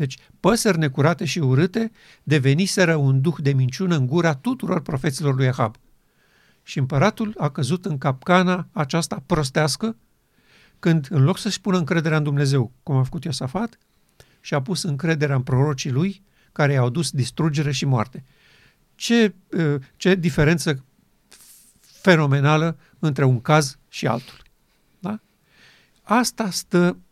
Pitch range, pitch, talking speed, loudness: 140-185 Hz, 155 Hz, 135 wpm, -21 LUFS